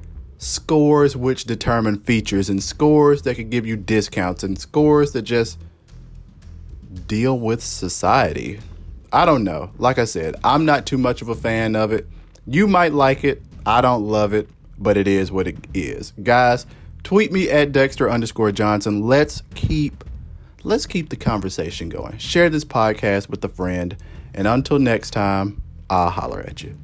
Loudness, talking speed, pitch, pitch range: -19 LUFS, 170 wpm, 110 Hz, 95-130 Hz